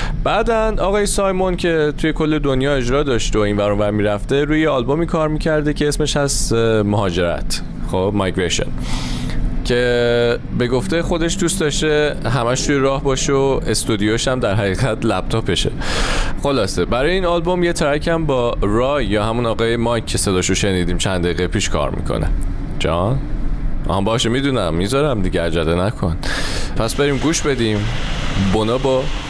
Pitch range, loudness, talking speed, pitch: 100-150 Hz, -18 LUFS, 150 wpm, 120 Hz